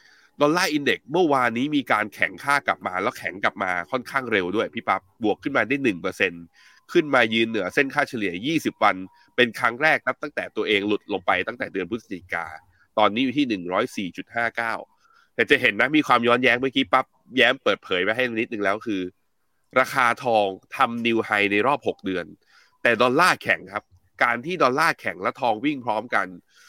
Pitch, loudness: 125 Hz, -22 LUFS